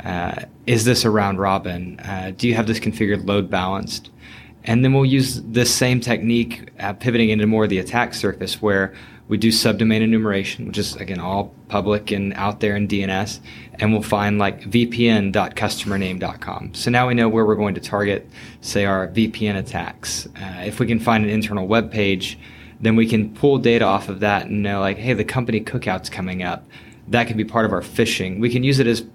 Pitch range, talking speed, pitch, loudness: 100-115 Hz, 205 wpm, 110 Hz, -20 LUFS